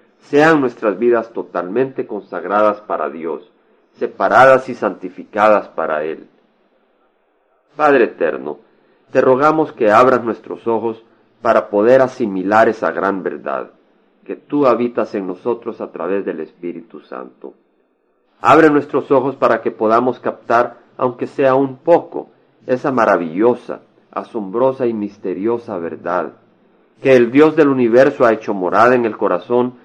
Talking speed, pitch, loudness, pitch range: 130 wpm, 120 Hz, -15 LUFS, 110-135 Hz